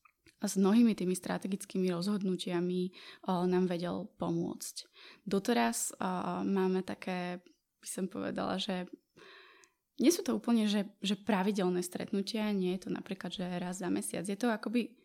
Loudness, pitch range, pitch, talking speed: -34 LUFS, 180-230 Hz, 195 Hz, 145 wpm